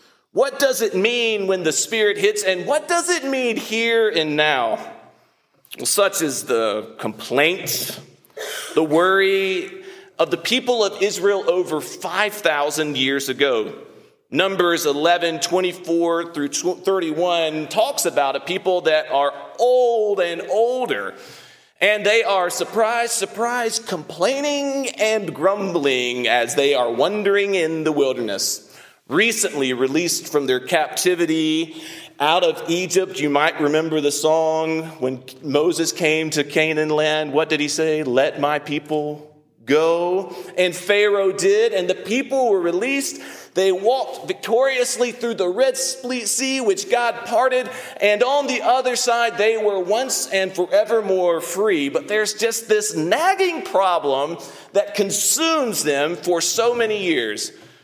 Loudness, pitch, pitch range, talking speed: -19 LUFS, 195 Hz, 160-245 Hz, 135 wpm